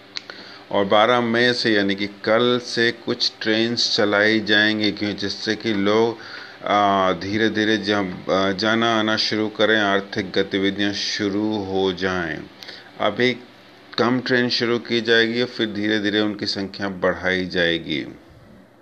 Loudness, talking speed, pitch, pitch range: -20 LUFS, 130 wpm, 105 Hz, 100-115 Hz